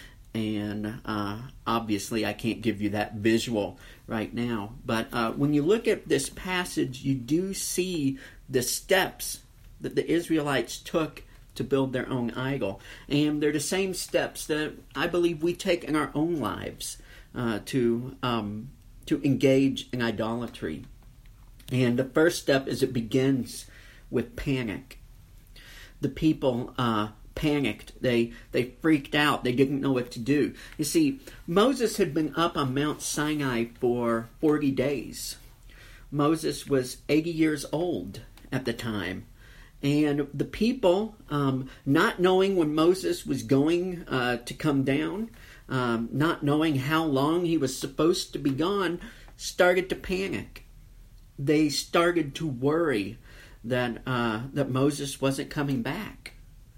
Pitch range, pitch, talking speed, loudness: 115-155 Hz, 135 Hz, 145 wpm, -27 LUFS